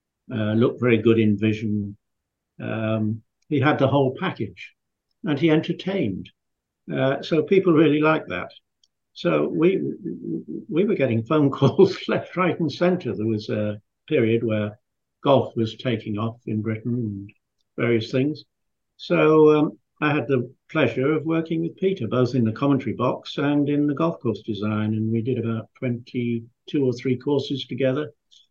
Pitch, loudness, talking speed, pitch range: 125 Hz, -23 LUFS, 160 wpm, 110-150 Hz